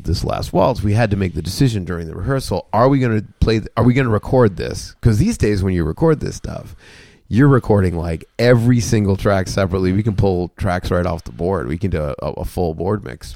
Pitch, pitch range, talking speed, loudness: 105 Hz, 90-115 Hz, 245 wpm, -18 LUFS